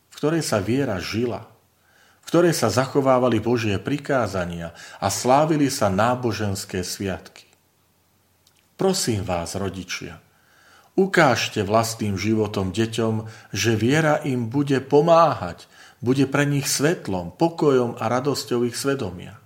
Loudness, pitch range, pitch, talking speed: -22 LUFS, 100-140 Hz, 115 Hz, 110 wpm